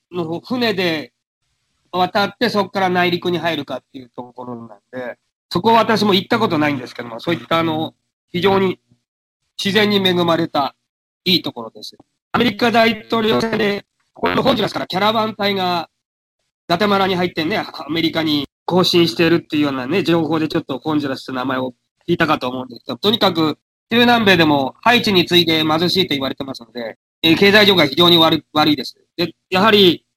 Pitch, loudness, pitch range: 170 Hz, -16 LUFS, 145-195 Hz